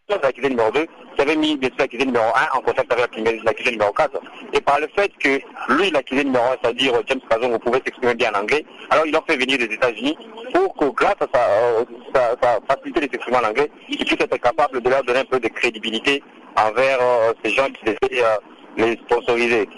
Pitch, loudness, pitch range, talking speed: 135 Hz, -19 LUFS, 120-200 Hz, 230 wpm